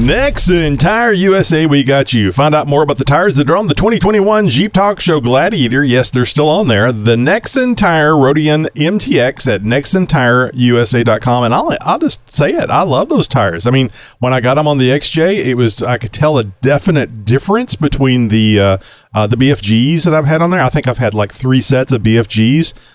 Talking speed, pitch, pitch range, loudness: 210 wpm, 135 Hz, 120-155 Hz, -11 LUFS